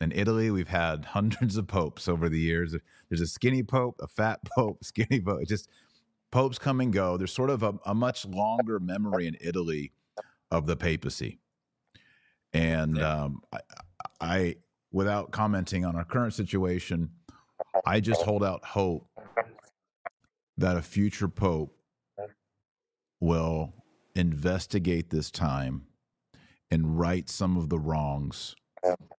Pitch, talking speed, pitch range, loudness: 90 Hz, 140 wpm, 85-105 Hz, -29 LUFS